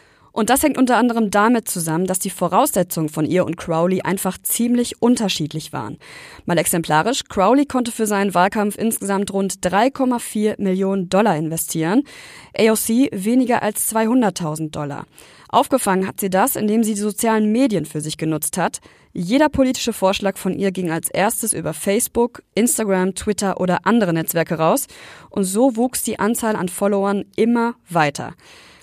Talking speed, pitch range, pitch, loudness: 155 wpm, 180-230 Hz, 200 Hz, -19 LUFS